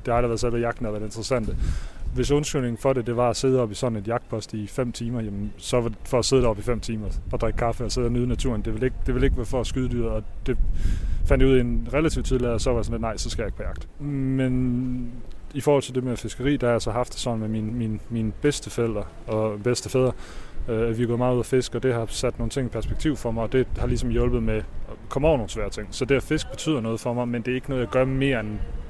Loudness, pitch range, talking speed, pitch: -25 LUFS, 110-130 Hz, 305 wpm, 120 Hz